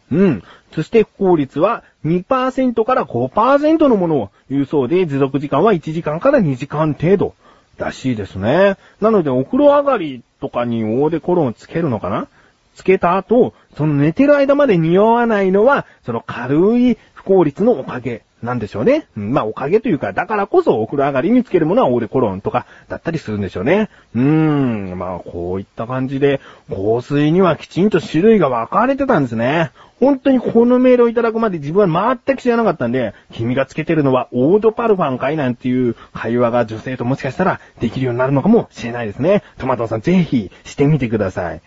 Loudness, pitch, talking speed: -16 LUFS, 155 Hz, 395 characters per minute